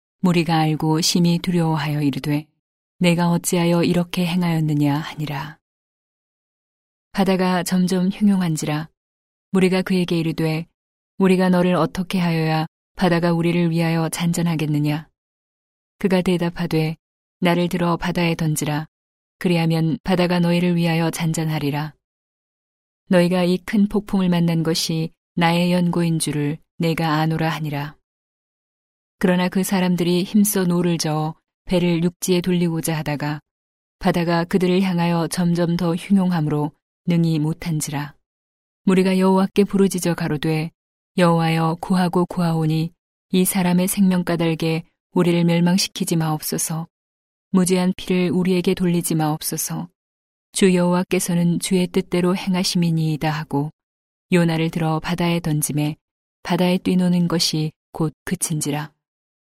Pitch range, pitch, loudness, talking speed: 155-180 Hz, 170 Hz, -20 LUFS, 295 characters per minute